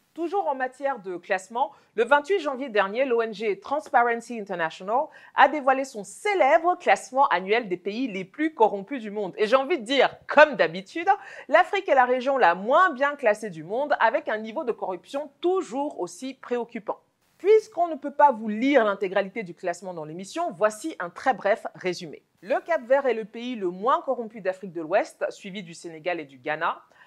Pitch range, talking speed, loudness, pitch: 200-290 Hz, 185 wpm, -25 LUFS, 245 Hz